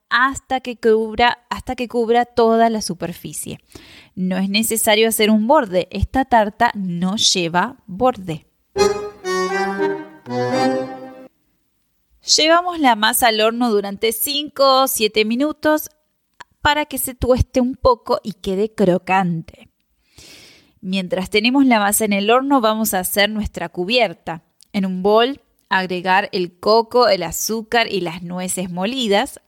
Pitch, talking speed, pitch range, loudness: 215 Hz, 130 wpm, 185-245 Hz, -17 LUFS